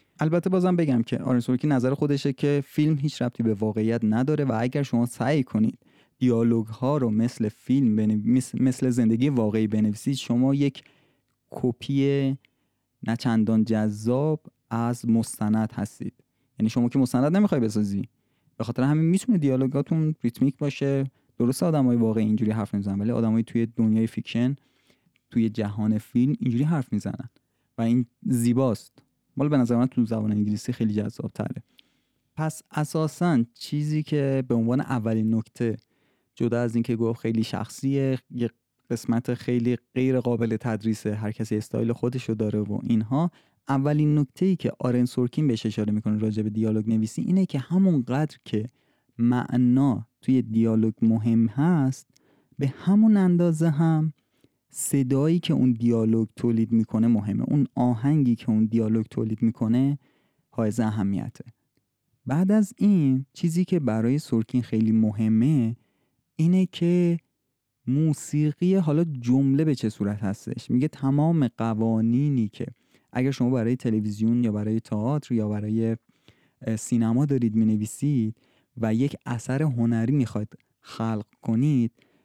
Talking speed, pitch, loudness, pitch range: 140 wpm, 120 Hz, -24 LUFS, 110-140 Hz